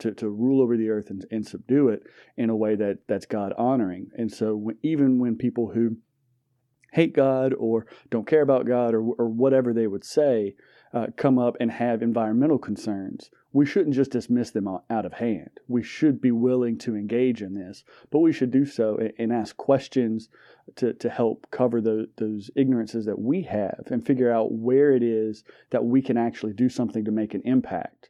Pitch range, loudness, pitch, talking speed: 110-130 Hz, -24 LUFS, 120 Hz, 205 wpm